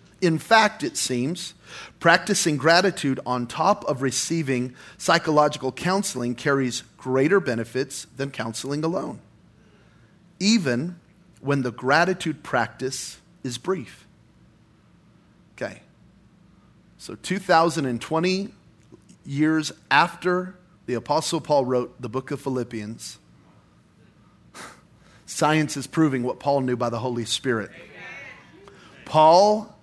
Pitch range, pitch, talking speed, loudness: 130-175 Hz, 150 Hz, 100 wpm, -23 LUFS